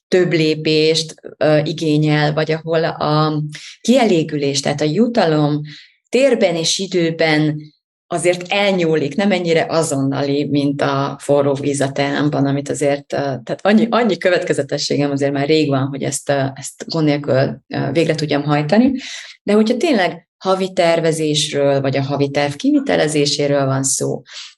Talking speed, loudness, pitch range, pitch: 140 wpm, -17 LUFS, 145-175 Hz, 155 Hz